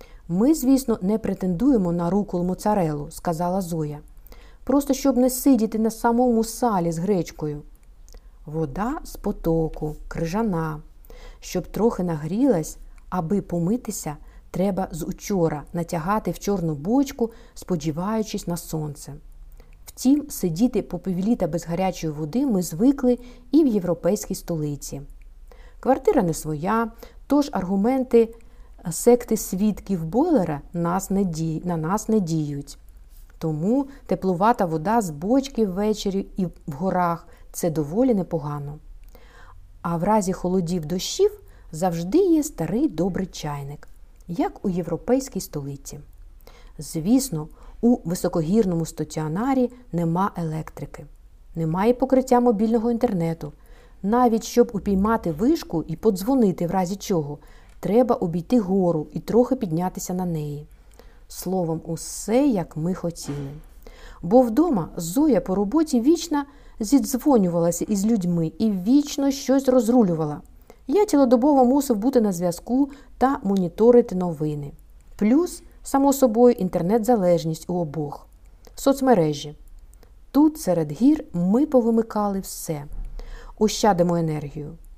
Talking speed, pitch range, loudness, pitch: 110 wpm, 165-240 Hz, -23 LUFS, 190 Hz